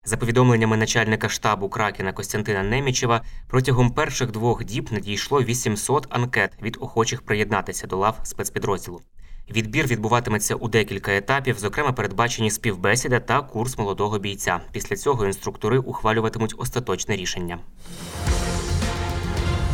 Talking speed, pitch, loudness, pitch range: 115 wpm, 110 Hz, -23 LUFS, 100-120 Hz